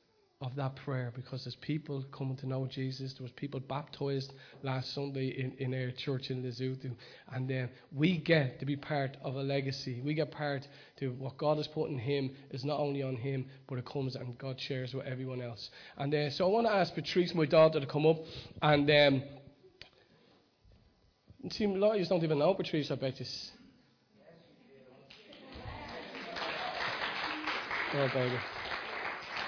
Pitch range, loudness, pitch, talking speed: 130-150 Hz, -34 LUFS, 135 Hz, 175 wpm